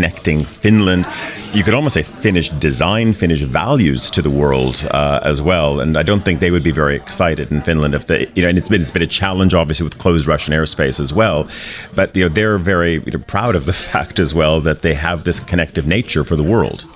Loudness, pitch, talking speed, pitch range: -15 LUFS, 85 Hz, 235 wpm, 75-95 Hz